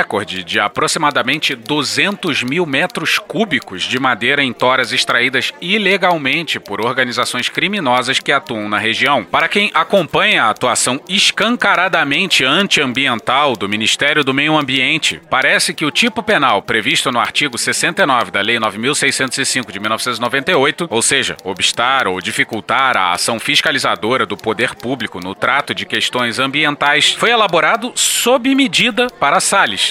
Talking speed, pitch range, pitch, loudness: 135 wpm, 120-180 Hz, 140 Hz, -14 LUFS